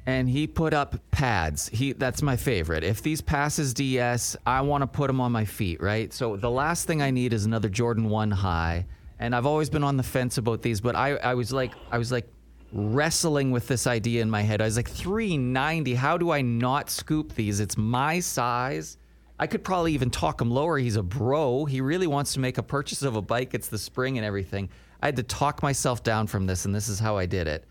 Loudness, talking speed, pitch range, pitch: -26 LUFS, 240 wpm, 110-140 Hz, 125 Hz